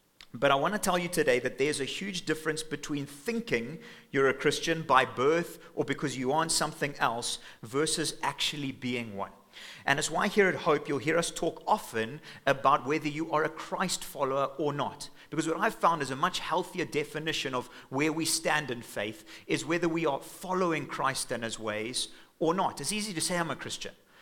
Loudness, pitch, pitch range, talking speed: -30 LUFS, 150 Hz, 135-165 Hz, 205 wpm